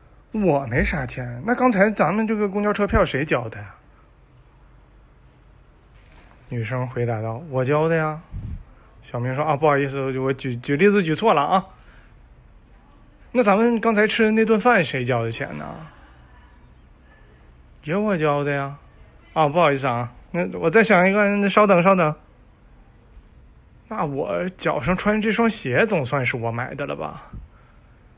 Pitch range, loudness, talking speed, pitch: 125-205 Hz, -21 LUFS, 215 characters per minute, 150 Hz